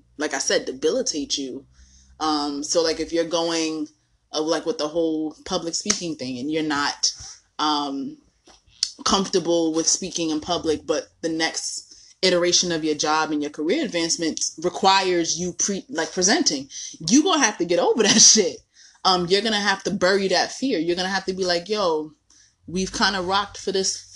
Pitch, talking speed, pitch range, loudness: 170 Hz, 180 wpm, 155-195 Hz, -21 LUFS